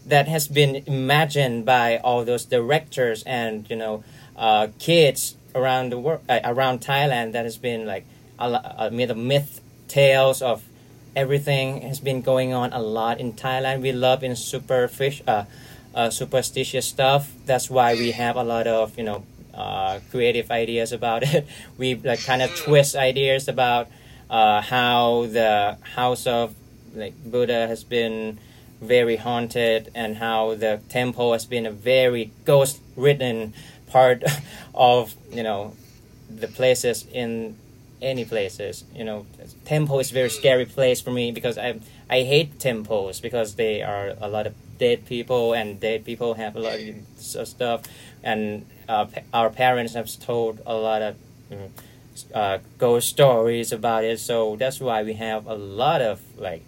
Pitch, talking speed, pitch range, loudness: 120 Hz, 160 wpm, 115-130 Hz, -22 LUFS